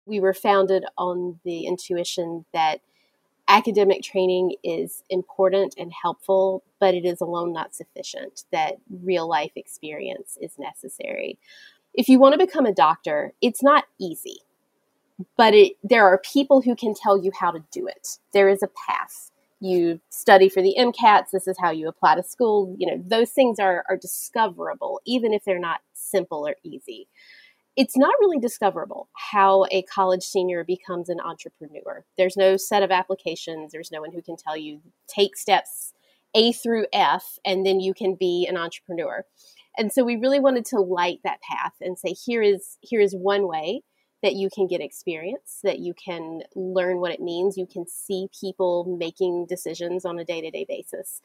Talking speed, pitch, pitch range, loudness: 175 wpm, 190 Hz, 180-220 Hz, -22 LUFS